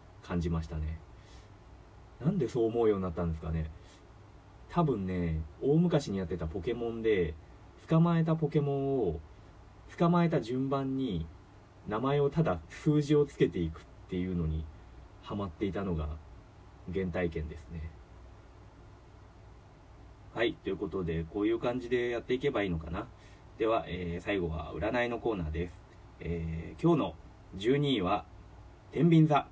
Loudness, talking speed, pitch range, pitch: -32 LUFS, 285 characters per minute, 85-120 Hz, 95 Hz